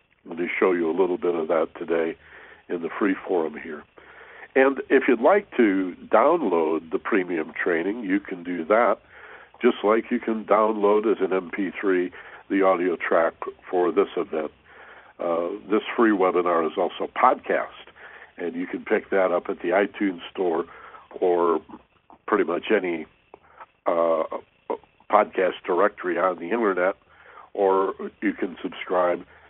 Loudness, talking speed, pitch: -24 LUFS, 150 wpm, 100 Hz